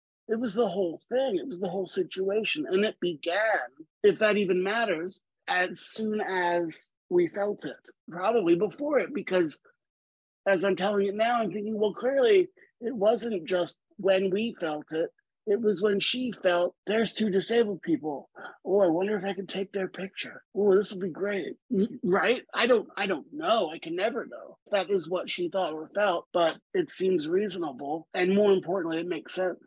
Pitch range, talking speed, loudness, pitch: 185-225 Hz, 190 wpm, -28 LUFS, 200 Hz